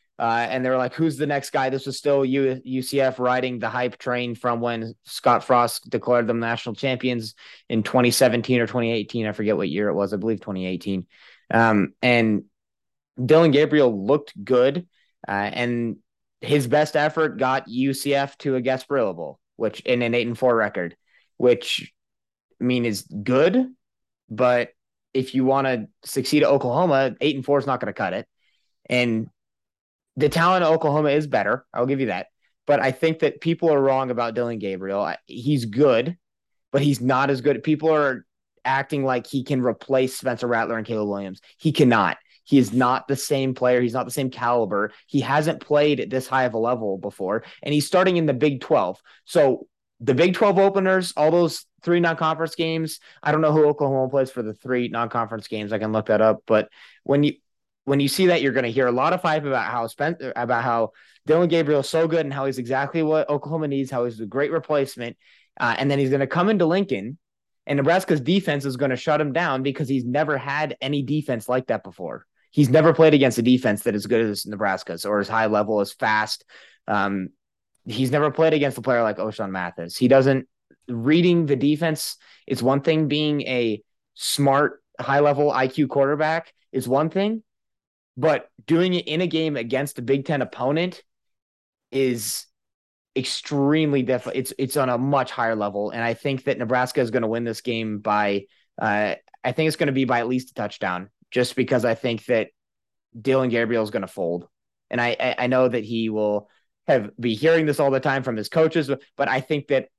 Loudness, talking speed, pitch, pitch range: -22 LUFS, 200 wpm, 130 Hz, 120-150 Hz